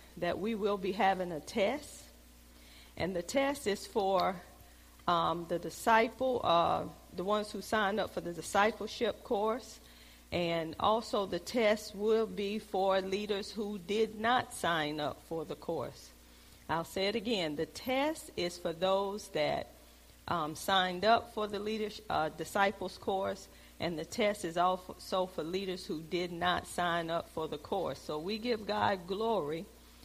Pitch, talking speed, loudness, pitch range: 185 Hz, 160 wpm, -34 LUFS, 160-210 Hz